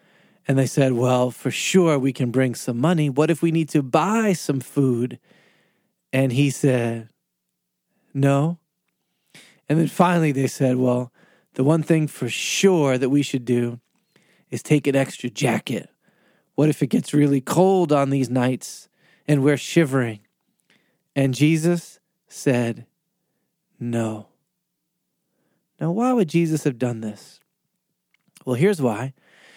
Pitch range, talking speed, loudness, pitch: 125-165 Hz, 140 wpm, -21 LUFS, 145 Hz